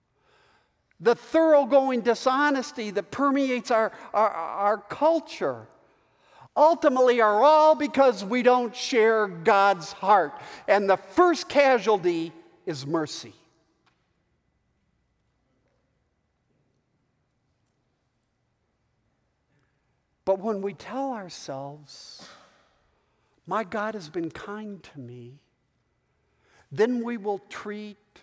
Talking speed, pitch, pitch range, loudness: 85 wpm, 210 Hz, 160-250 Hz, -23 LUFS